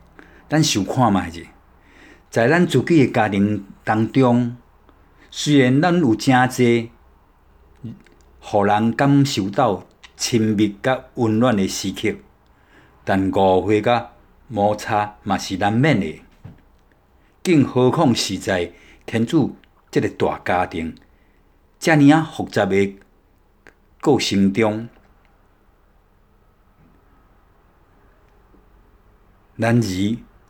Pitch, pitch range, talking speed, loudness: 105 Hz, 95-120 Hz, 130 characters per minute, -19 LUFS